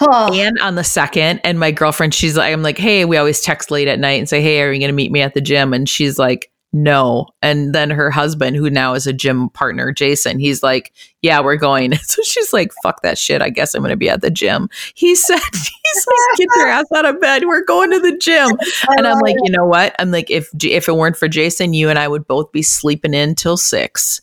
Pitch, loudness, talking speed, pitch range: 155 Hz, -13 LUFS, 260 wpm, 145-200 Hz